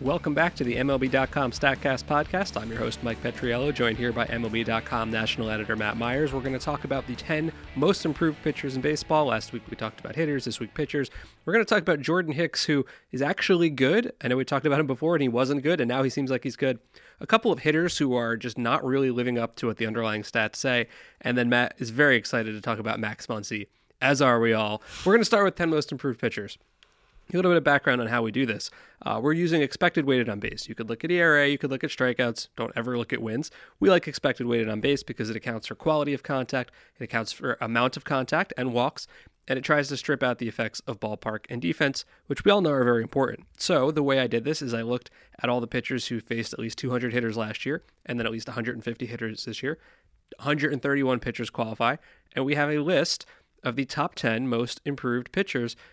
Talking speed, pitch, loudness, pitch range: 245 wpm, 130 Hz, -26 LUFS, 115-145 Hz